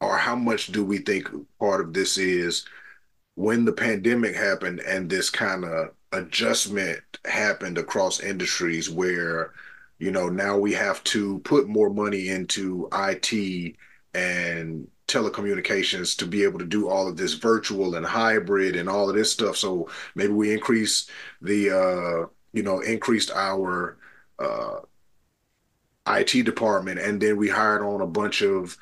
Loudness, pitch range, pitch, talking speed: -24 LUFS, 90-105 Hz, 100 Hz, 150 wpm